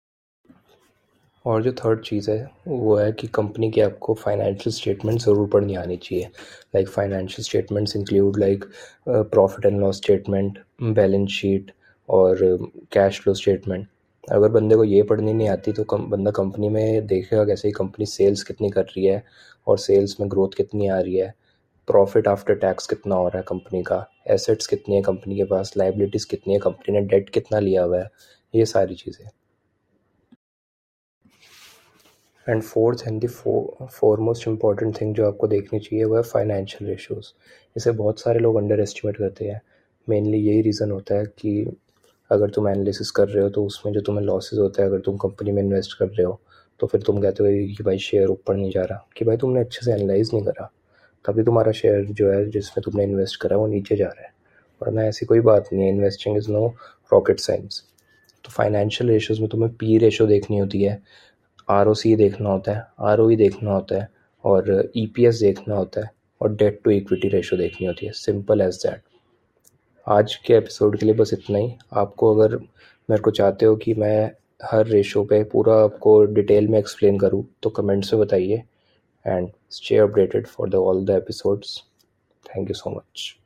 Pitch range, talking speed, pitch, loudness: 100-110 Hz, 190 wpm, 105 Hz, -21 LUFS